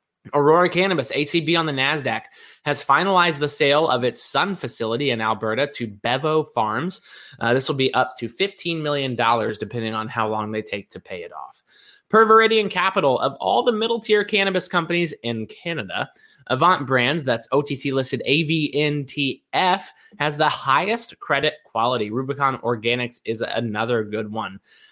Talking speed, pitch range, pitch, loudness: 160 wpm, 115-165 Hz, 140 Hz, -21 LUFS